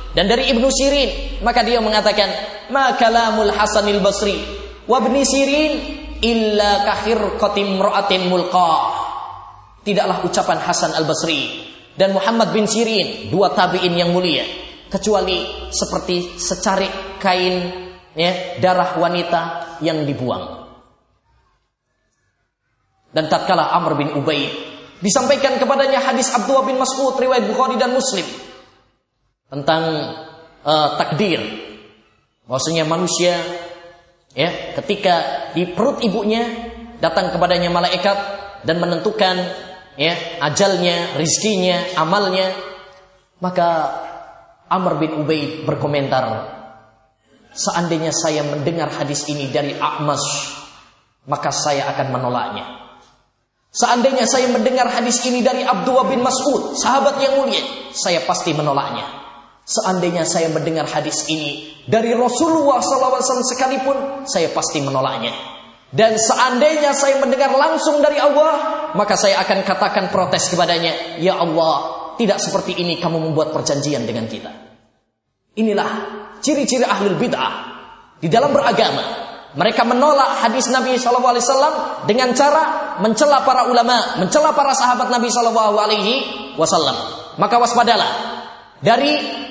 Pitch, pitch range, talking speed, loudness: 195 Hz, 160-250 Hz, 110 wpm, -17 LUFS